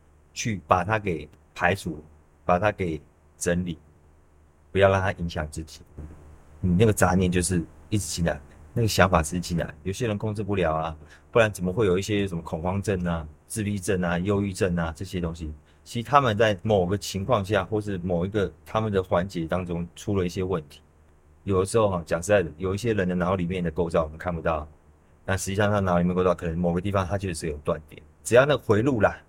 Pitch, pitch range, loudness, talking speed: 90 Hz, 80-100 Hz, -25 LUFS, 320 characters per minute